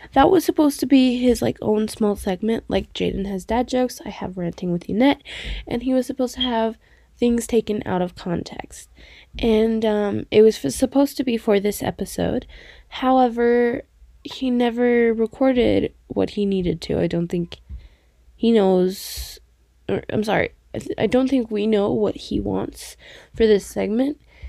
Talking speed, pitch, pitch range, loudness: 175 wpm, 225 Hz, 200-250 Hz, -21 LUFS